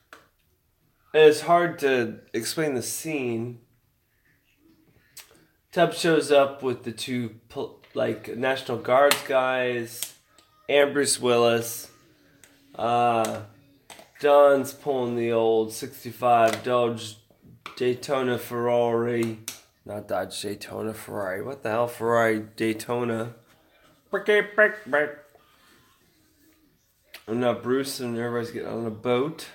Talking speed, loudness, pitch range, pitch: 95 wpm, -24 LUFS, 115-140 Hz, 120 Hz